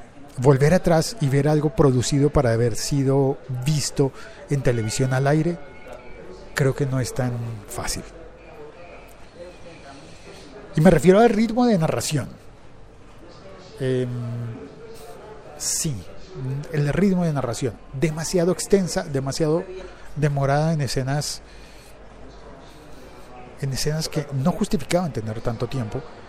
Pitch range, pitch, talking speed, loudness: 125-160 Hz, 140 Hz, 105 wpm, -22 LUFS